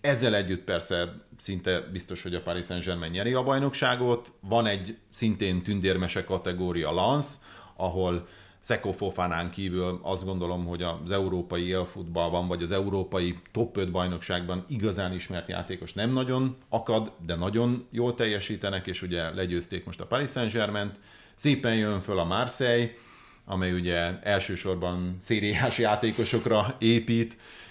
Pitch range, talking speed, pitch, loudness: 90-115 Hz, 130 wpm, 95 Hz, -29 LUFS